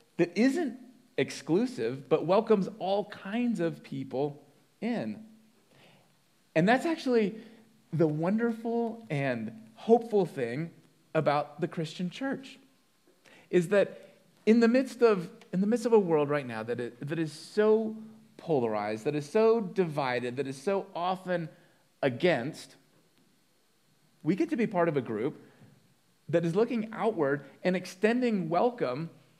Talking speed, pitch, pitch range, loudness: 135 wpm, 185 Hz, 155-225 Hz, -29 LUFS